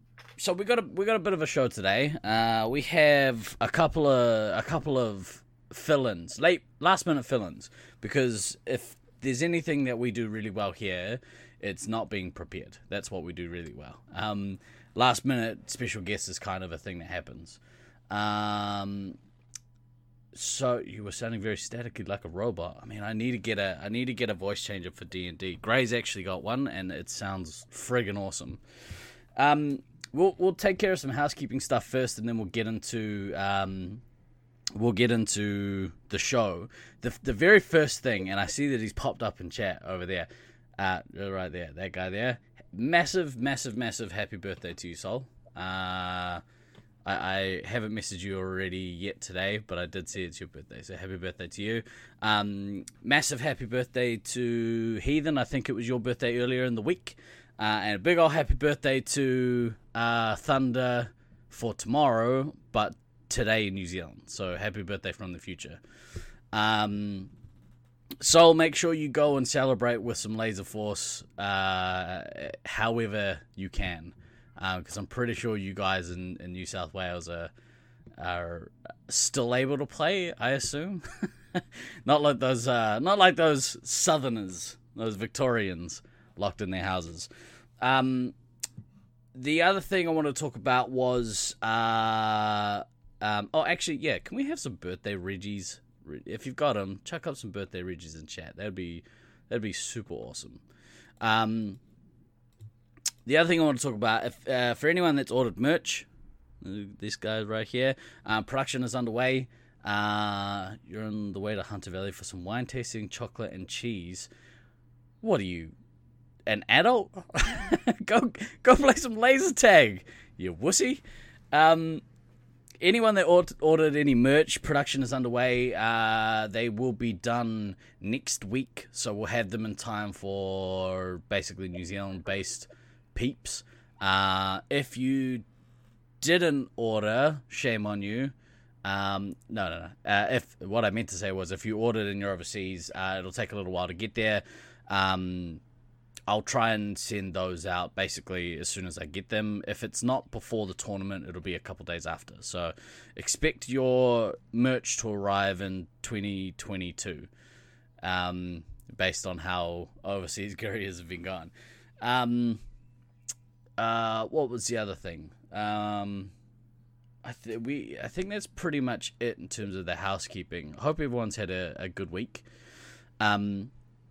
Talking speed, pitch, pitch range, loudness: 165 wpm, 115 Hz, 95-125 Hz, -29 LUFS